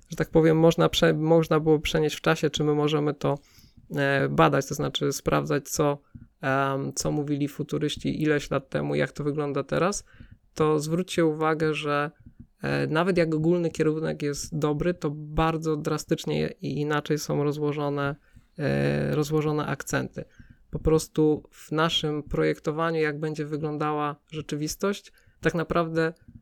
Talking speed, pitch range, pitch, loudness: 130 wpm, 145-160 Hz, 150 Hz, -26 LUFS